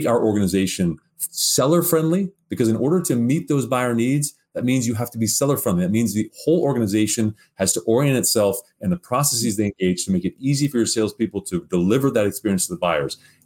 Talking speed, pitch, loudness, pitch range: 215 wpm, 120 Hz, -20 LUFS, 105-145 Hz